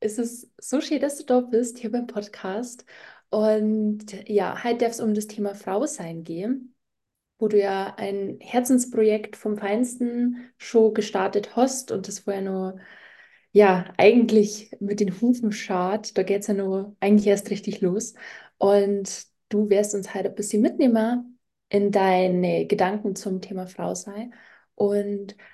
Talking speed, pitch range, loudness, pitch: 160 wpm, 200-230 Hz, -24 LUFS, 210 Hz